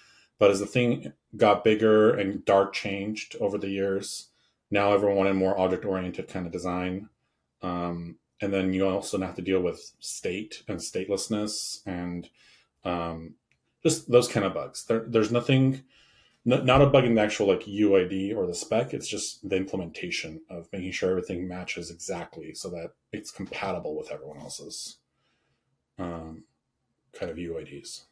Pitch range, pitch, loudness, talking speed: 90-110 Hz, 100 Hz, -27 LUFS, 160 wpm